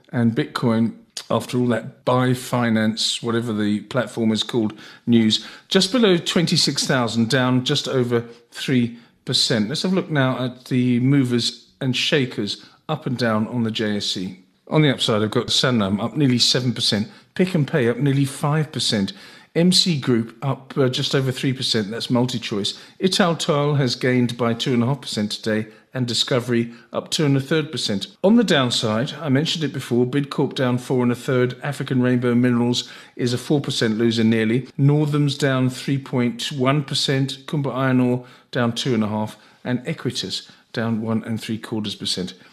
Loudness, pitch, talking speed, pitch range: -21 LUFS, 125 Hz, 185 wpm, 115-140 Hz